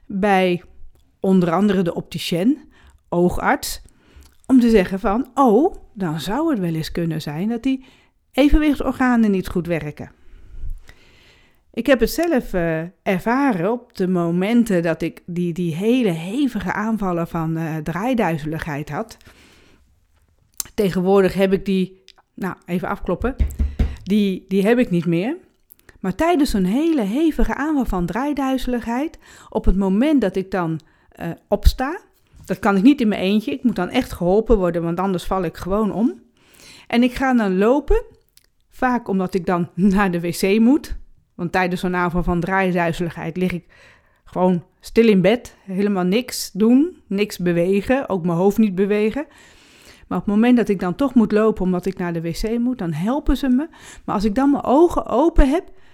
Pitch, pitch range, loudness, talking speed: 200 Hz, 175-245 Hz, -20 LUFS, 165 wpm